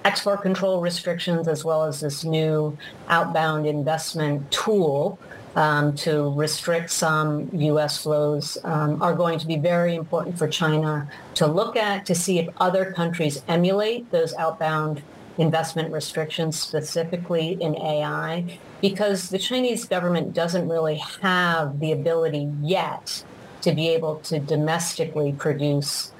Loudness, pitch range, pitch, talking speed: -23 LUFS, 155-175 Hz, 160 Hz, 135 wpm